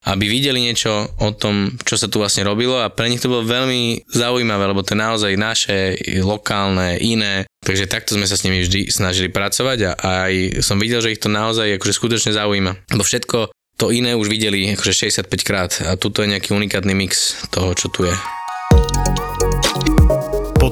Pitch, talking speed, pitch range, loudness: 105 Hz, 180 wpm, 95-115 Hz, -17 LUFS